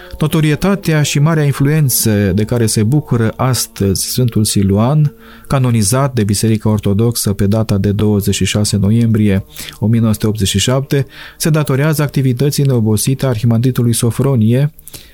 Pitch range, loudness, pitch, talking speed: 105-140 Hz, -13 LUFS, 115 Hz, 110 wpm